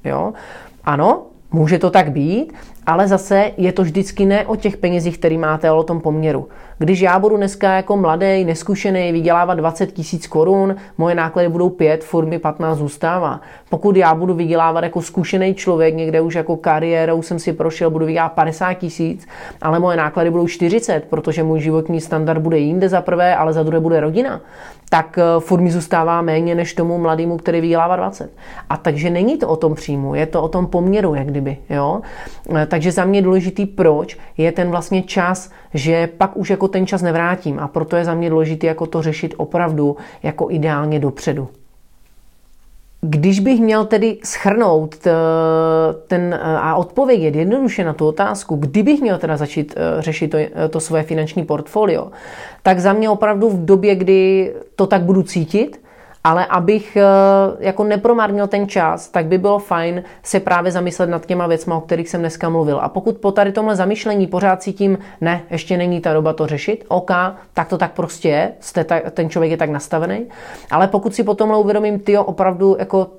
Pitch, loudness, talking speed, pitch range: 175 Hz, -16 LUFS, 180 wpm, 160-195 Hz